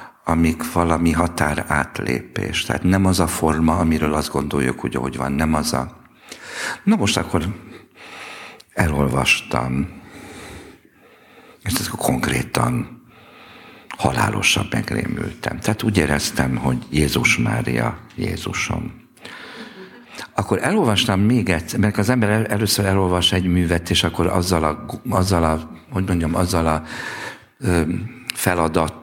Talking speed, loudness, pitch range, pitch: 110 wpm, -20 LUFS, 80-105 Hz, 90 Hz